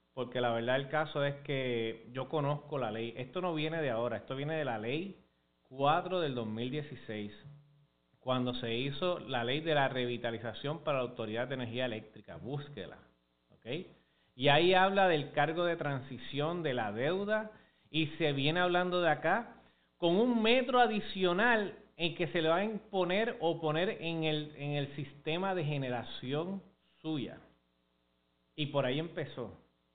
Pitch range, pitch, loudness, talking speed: 120-165 Hz, 145 Hz, -34 LUFS, 160 wpm